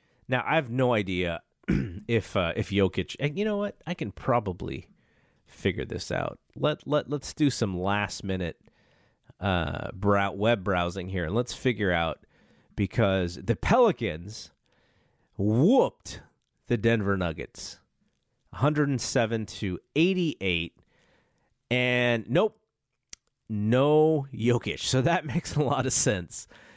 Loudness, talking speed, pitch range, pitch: -27 LUFS, 135 wpm, 95-145 Hz, 115 Hz